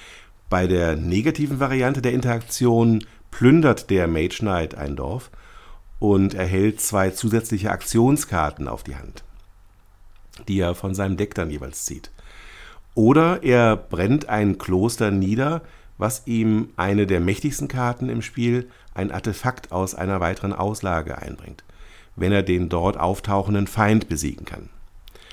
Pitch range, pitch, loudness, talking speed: 90-115 Hz, 100 Hz, -21 LUFS, 135 wpm